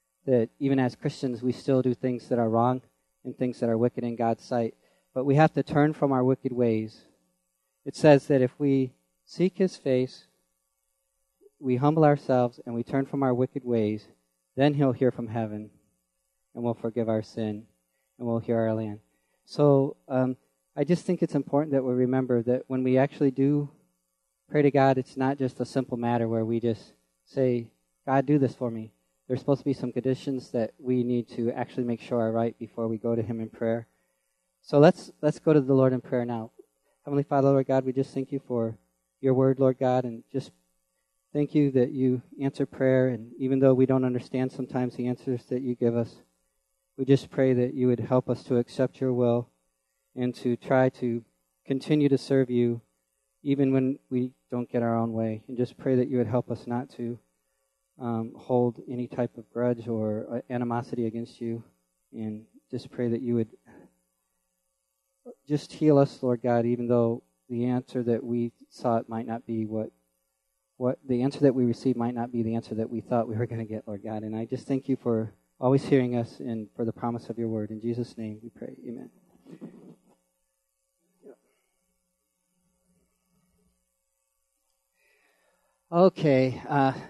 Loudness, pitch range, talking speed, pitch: -27 LUFS, 110-130 Hz, 190 wpm, 120 Hz